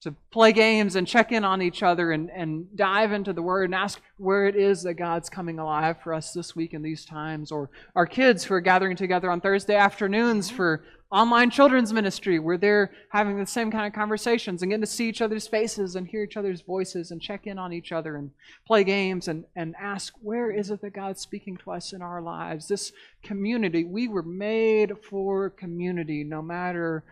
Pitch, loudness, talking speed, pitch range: 190 Hz, -25 LUFS, 215 wpm, 170-210 Hz